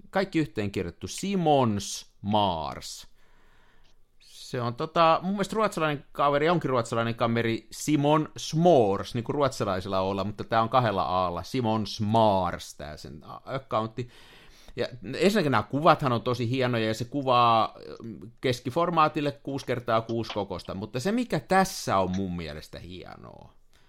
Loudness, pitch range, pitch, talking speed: -26 LUFS, 105-145 Hz, 120 Hz, 135 wpm